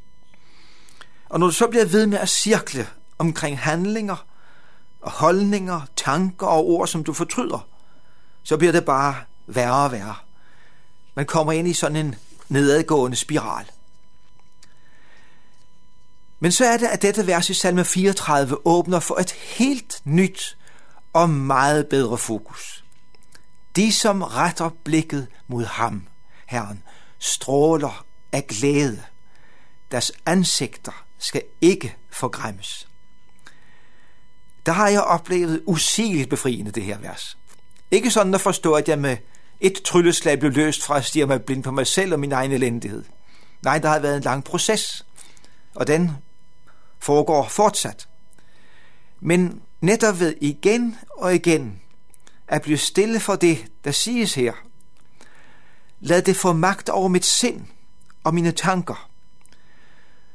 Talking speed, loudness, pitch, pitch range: 135 wpm, -20 LUFS, 160 Hz, 140-185 Hz